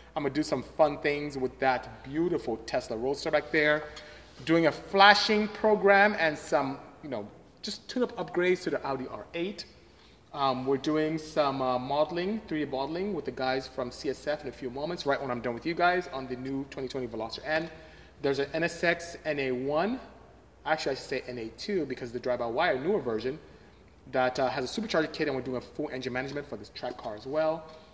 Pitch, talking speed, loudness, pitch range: 150 Hz, 200 wpm, -29 LUFS, 130-165 Hz